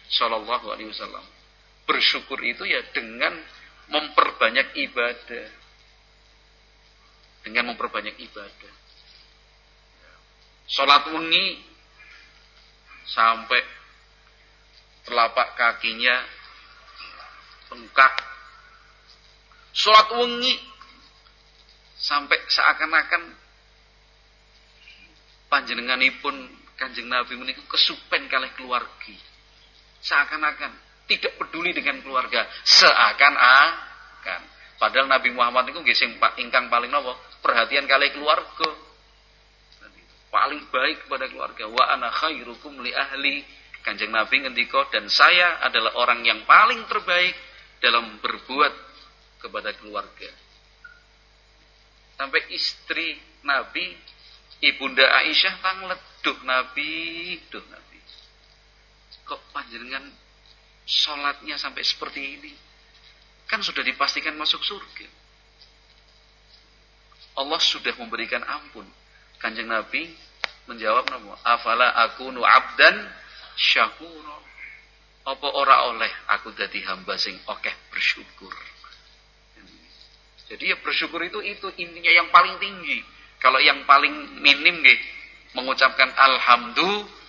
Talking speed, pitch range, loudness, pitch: 85 wpm, 130-180 Hz, -20 LUFS, 145 Hz